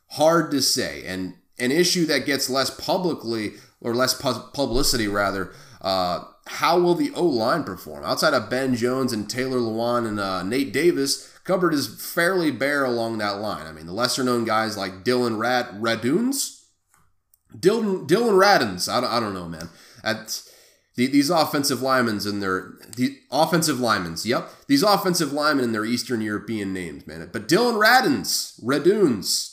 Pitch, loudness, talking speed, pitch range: 125 Hz, -22 LUFS, 165 wpm, 105-145 Hz